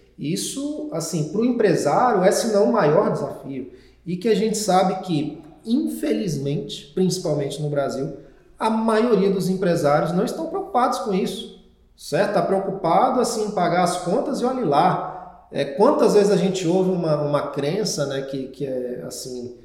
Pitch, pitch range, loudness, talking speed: 185 Hz, 145-215 Hz, -21 LUFS, 165 wpm